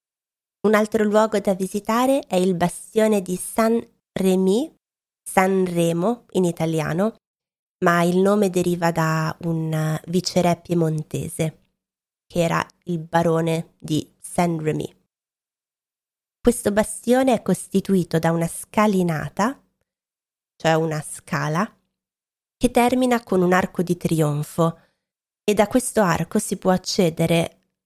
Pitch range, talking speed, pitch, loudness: 165-210 Hz, 120 wpm, 180 Hz, -21 LUFS